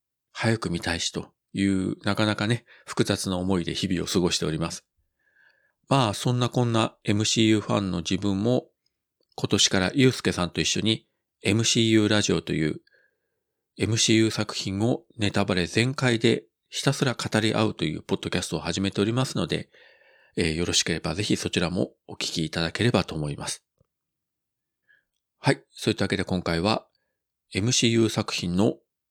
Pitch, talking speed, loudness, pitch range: 105 Hz, 330 characters per minute, -25 LUFS, 95-115 Hz